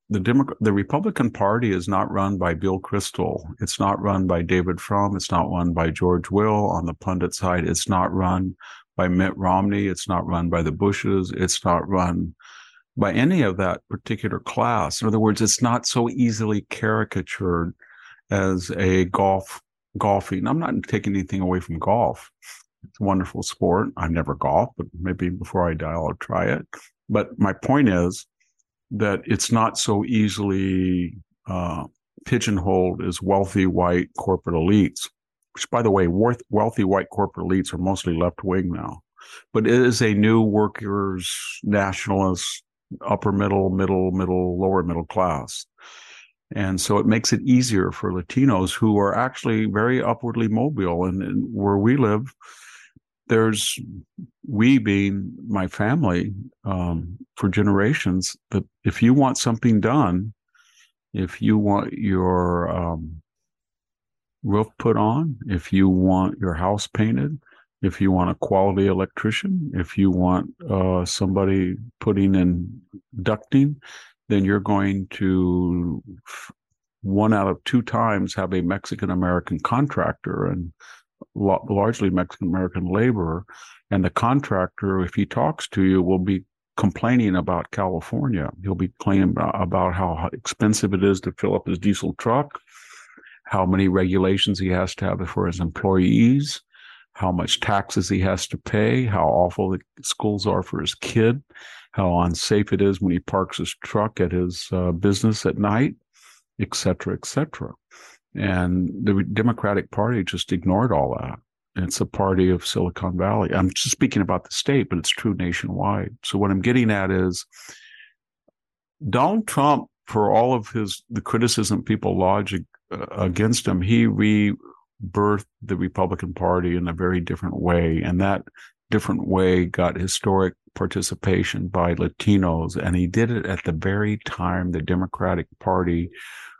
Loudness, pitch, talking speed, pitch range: -22 LUFS, 95 Hz, 155 wpm, 90-105 Hz